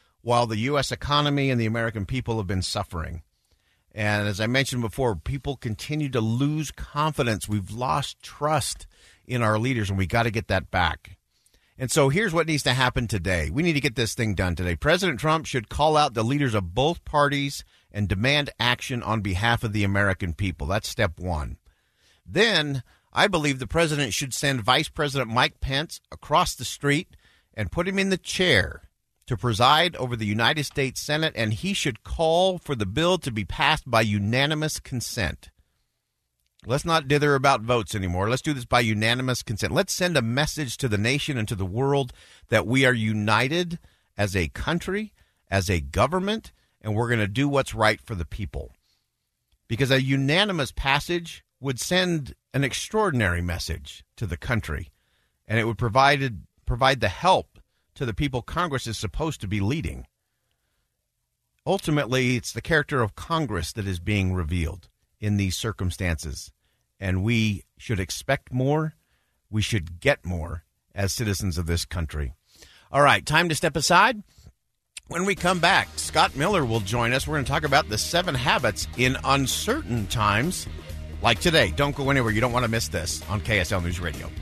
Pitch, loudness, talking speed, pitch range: 120 Hz, -24 LUFS, 180 wpm, 100-145 Hz